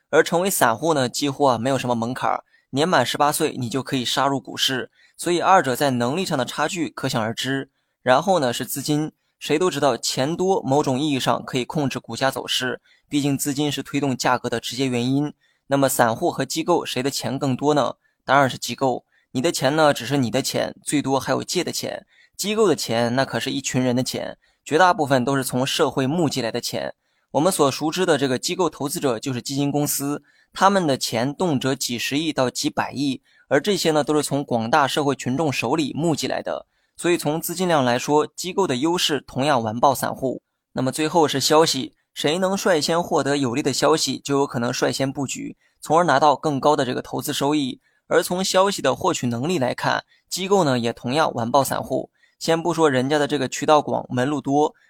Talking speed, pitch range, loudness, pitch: 315 characters per minute, 130-155 Hz, -21 LUFS, 140 Hz